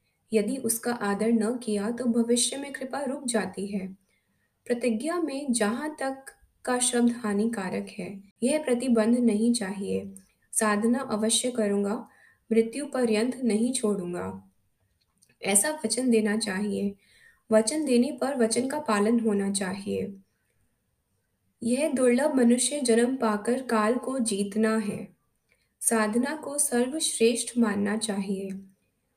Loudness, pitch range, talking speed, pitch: -26 LUFS, 200-250 Hz, 115 wpm, 225 Hz